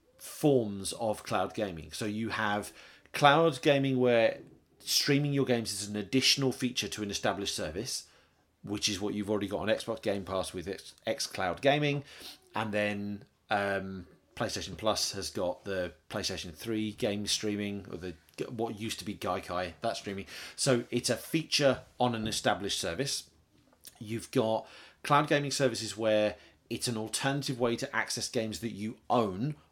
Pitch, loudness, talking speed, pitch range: 110 Hz, -31 LUFS, 160 wpm, 100-125 Hz